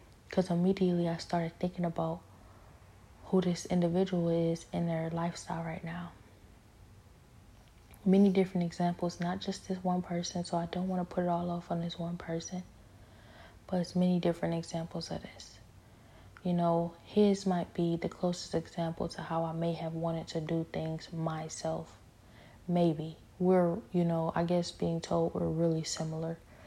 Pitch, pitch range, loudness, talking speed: 170 Hz, 155-175 Hz, -33 LUFS, 160 wpm